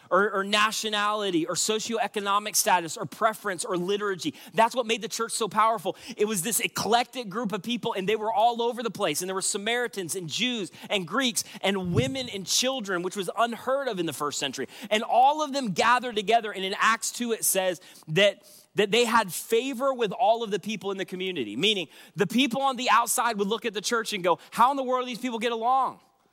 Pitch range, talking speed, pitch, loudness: 195-235 Hz, 225 wpm, 220 Hz, -26 LUFS